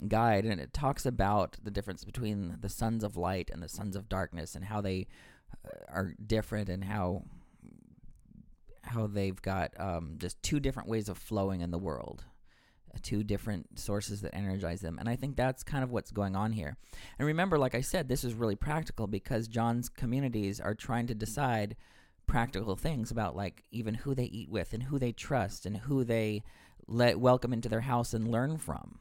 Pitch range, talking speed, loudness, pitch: 95-120 Hz, 190 wpm, -34 LUFS, 105 Hz